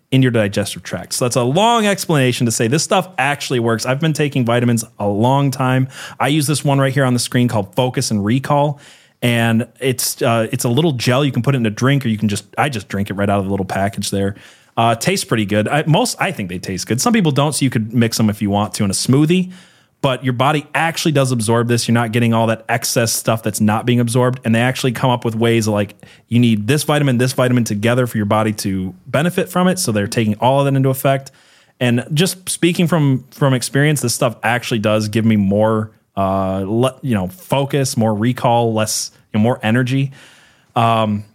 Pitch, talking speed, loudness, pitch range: 120 Hz, 240 wpm, -16 LUFS, 110-140 Hz